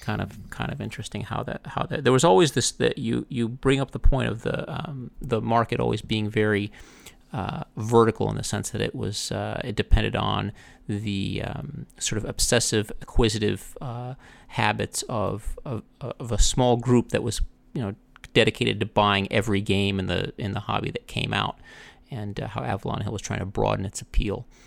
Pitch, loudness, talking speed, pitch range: 110 Hz, -26 LUFS, 200 wpm, 100-125 Hz